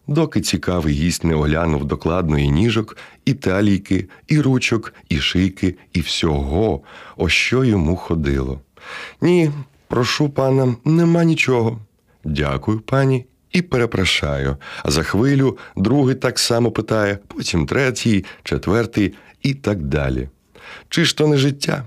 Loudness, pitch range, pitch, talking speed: -18 LUFS, 85-130 Hz, 110 Hz, 130 wpm